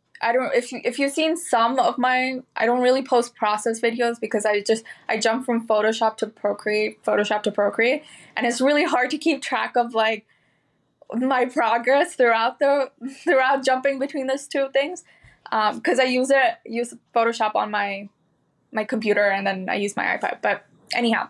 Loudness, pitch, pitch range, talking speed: -22 LUFS, 240 Hz, 220-265 Hz, 185 wpm